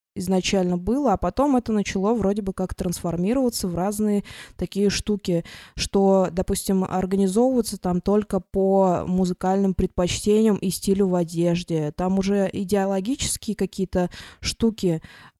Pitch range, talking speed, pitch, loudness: 185-205 Hz, 120 wpm, 195 Hz, -23 LUFS